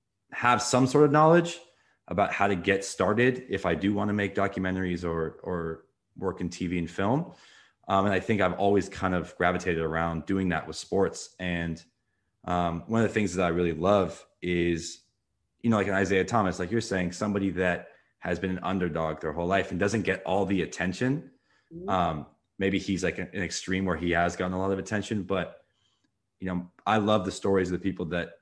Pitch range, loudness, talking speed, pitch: 90-100 Hz, -28 LUFS, 205 wpm, 95 Hz